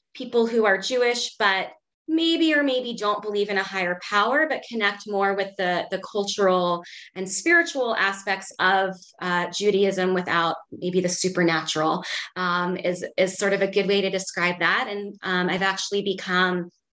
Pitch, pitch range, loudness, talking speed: 195 Hz, 180-205 Hz, -23 LUFS, 165 wpm